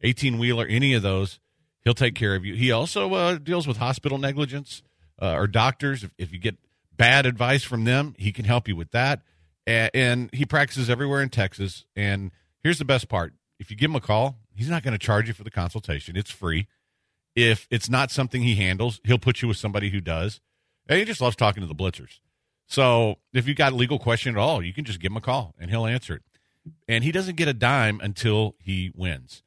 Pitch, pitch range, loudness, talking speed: 115 Hz, 100-135 Hz, -24 LUFS, 230 wpm